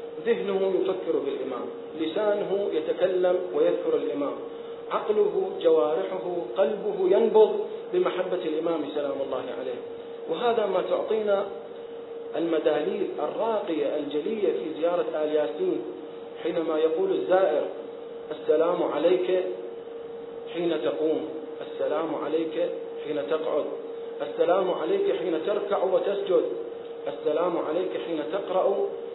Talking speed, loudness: 95 wpm, -27 LUFS